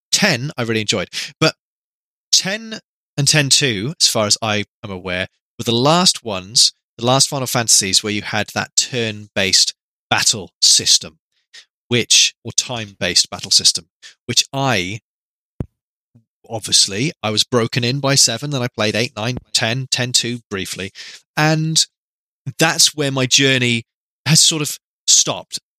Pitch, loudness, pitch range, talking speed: 125 Hz, -15 LUFS, 110-145 Hz, 150 wpm